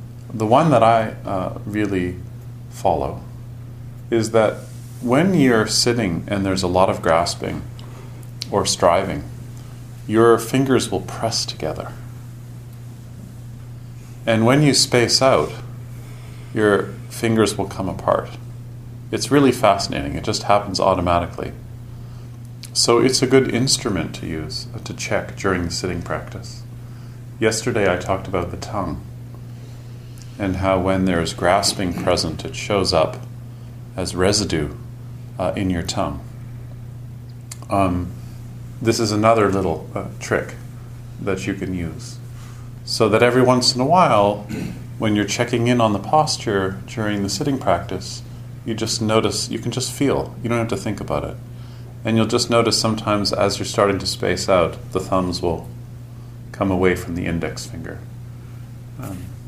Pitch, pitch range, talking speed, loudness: 120 Hz, 105-120 Hz, 145 wpm, -19 LUFS